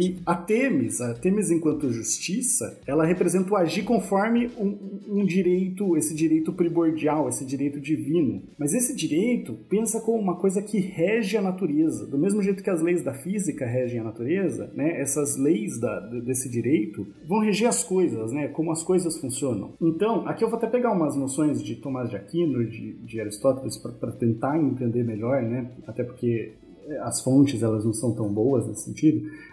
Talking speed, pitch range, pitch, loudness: 180 wpm, 130-195 Hz, 160 Hz, -25 LUFS